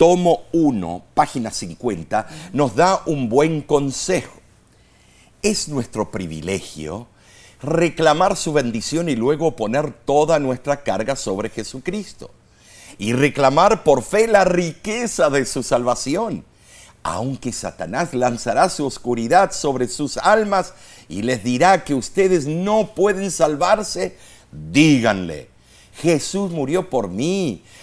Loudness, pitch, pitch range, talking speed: -19 LUFS, 145 Hz, 120-180 Hz, 115 wpm